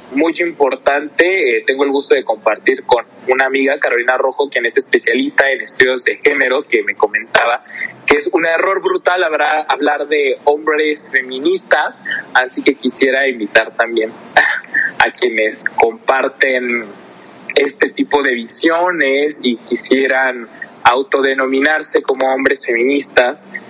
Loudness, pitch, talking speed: -14 LUFS, 150 Hz, 125 wpm